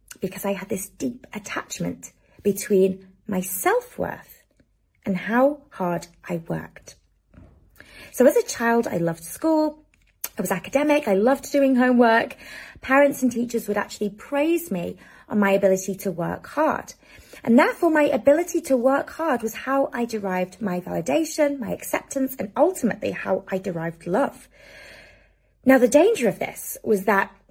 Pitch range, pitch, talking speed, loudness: 190-280 Hz, 235 Hz, 155 wpm, -23 LUFS